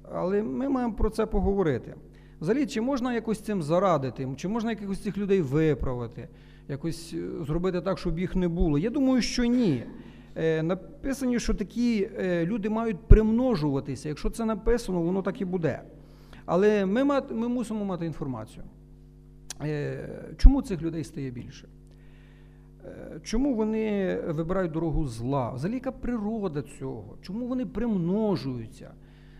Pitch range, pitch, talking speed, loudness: 160-225 Hz, 195 Hz, 135 wpm, -28 LUFS